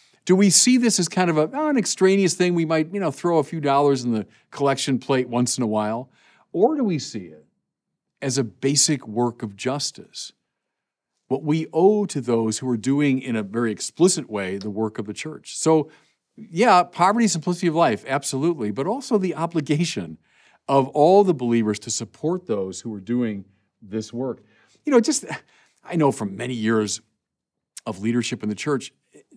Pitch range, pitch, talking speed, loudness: 115-175 Hz, 135 Hz, 190 wpm, -21 LUFS